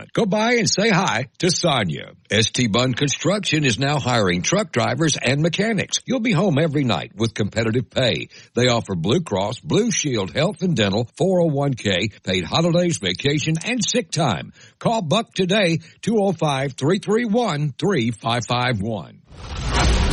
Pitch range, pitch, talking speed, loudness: 120-185 Hz, 150 Hz, 140 wpm, -20 LUFS